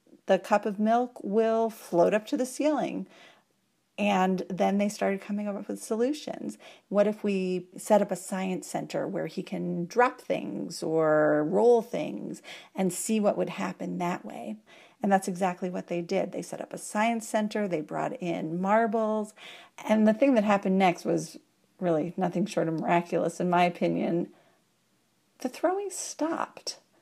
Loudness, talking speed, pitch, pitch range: -28 LUFS, 165 wpm, 200 Hz, 175-220 Hz